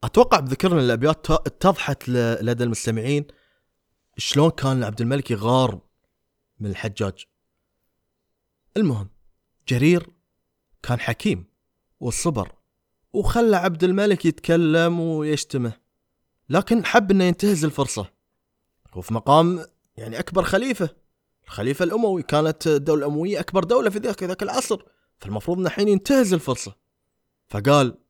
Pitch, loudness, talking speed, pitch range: 155 Hz, -21 LUFS, 105 wpm, 120-185 Hz